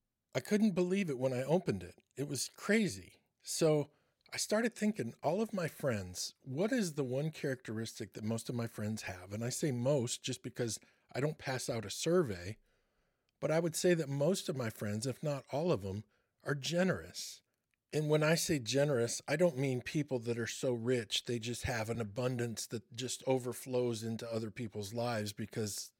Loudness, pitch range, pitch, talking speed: -36 LUFS, 115-155 Hz, 130 Hz, 195 wpm